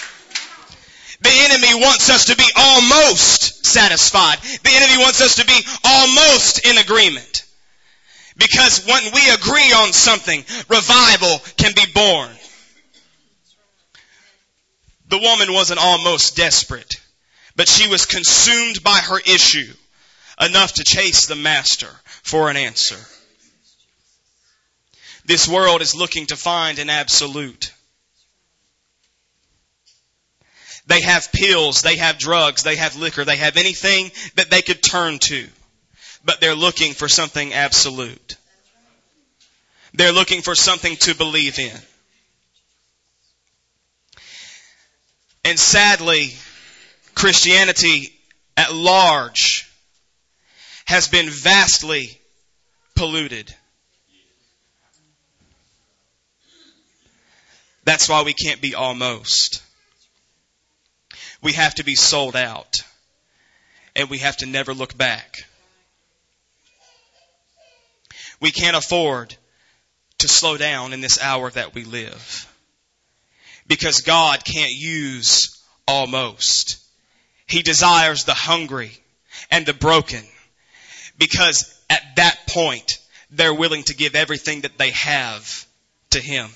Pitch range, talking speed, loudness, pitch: 135-185 Hz, 105 wpm, -13 LUFS, 155 Hz